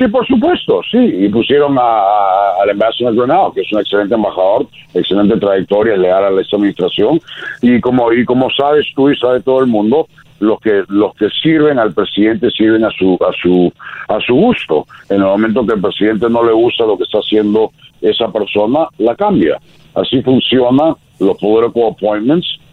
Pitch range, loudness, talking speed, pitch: 105-140 Hz, -12 LUFS, 185 wpm, 120 Hz